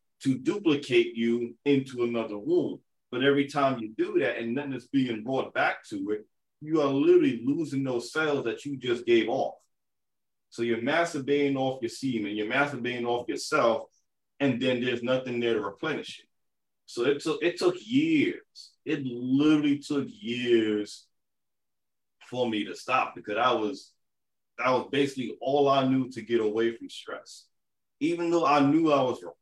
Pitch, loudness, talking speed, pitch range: 135 Hz, -27 LUFS, 175 wpm, 120-150 Hz